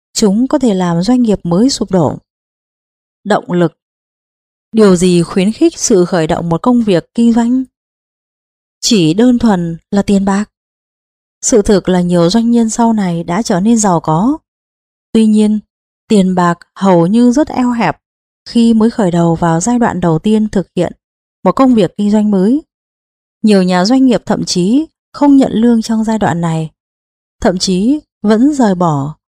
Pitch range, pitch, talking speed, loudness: 175-235 Hz, 210 Hz, 175 wpm, -11 LUFS